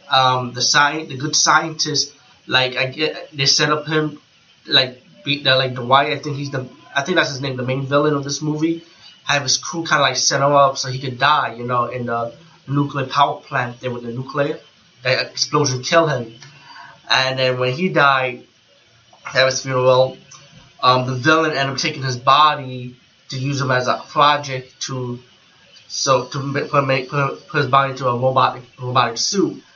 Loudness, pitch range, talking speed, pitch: -18 LUFS, 130-150 Hz, 200 wpm, 135 Hz